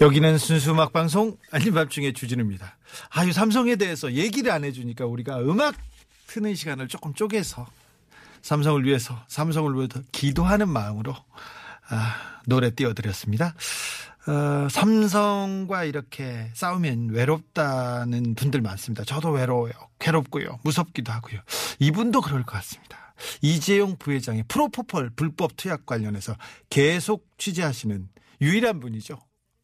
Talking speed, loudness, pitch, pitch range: 325 characters per minute, -25 LUFS, 145 Hz, 120-175 Hz